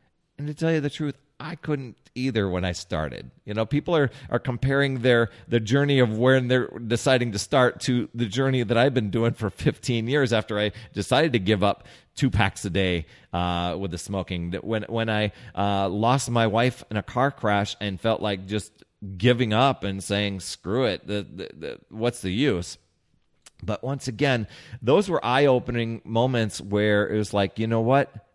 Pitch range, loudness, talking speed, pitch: 100-130 Hz, -24 LUFS, 195 wpm, 115 Hz